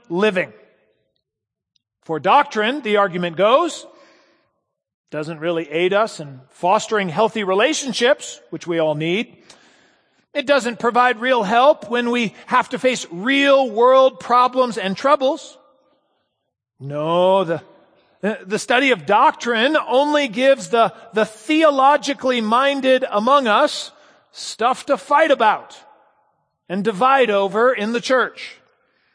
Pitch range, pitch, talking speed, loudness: 190-275 Hz, 240 Hz, 115 wpm, -17 LUFS